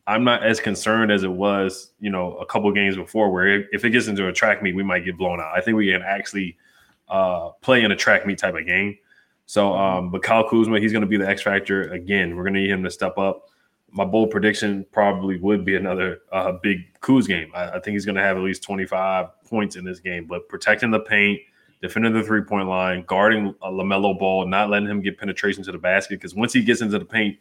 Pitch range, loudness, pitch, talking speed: 95-105 Hz, -21 LUFS, 100 Hz, 250 wpm